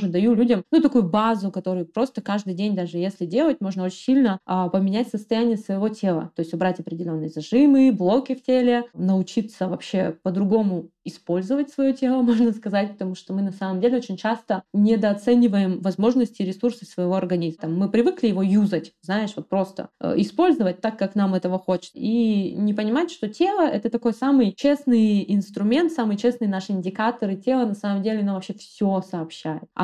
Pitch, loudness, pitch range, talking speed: 205 Hz, -22 LUFS, 185-235 Hz, 170 wpm